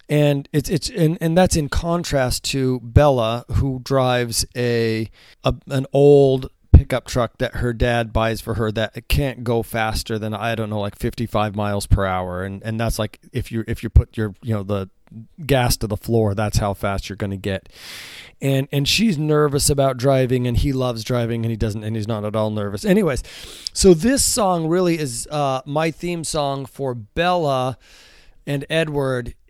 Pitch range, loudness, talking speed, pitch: 110-140 Hz, -20 LUFS, 190 wpm, 120 Hz